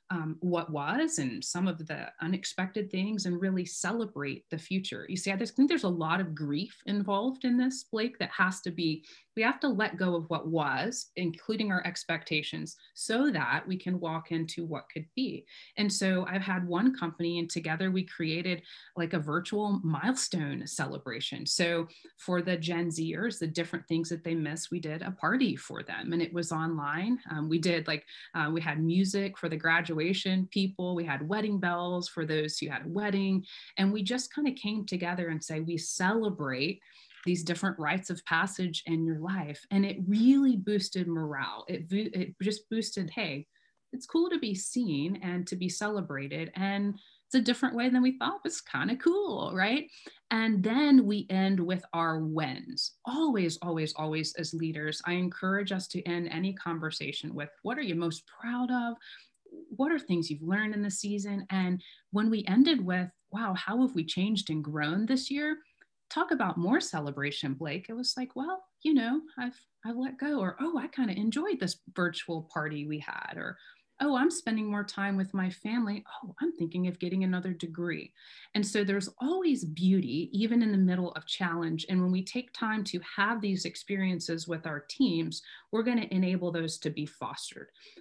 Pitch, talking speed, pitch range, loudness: 185 Hz, 195 wpm, 165-220 Hz, -31 LUFS